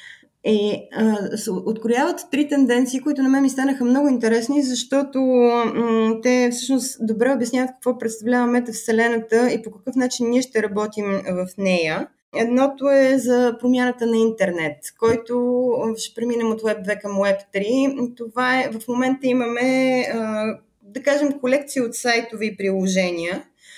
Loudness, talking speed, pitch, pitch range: -20 LUFS, 150 wpm, 240 Hz, 220-255 Hz